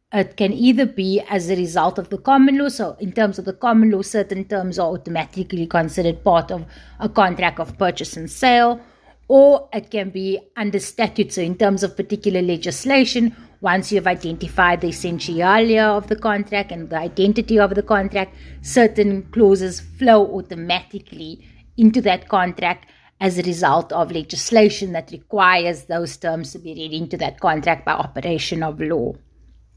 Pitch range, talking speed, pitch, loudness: 175-210 Hz, 170 wpm, 190 Hz, -18 LUFS